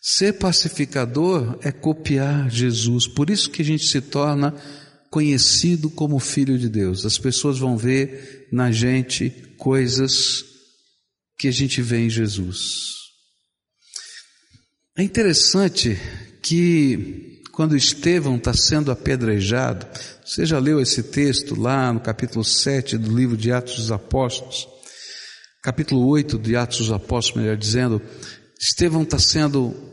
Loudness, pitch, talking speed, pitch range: -20 LUFS, 130 Hz, 130 wpm, 120-145 Hz